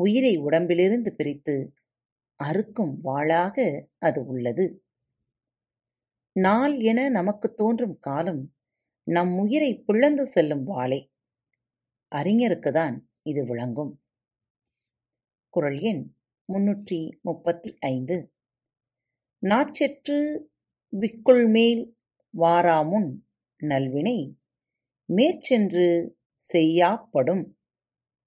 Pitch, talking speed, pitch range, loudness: 170 Hz, 65 wpm, 130-215 Hz, -24 LUFS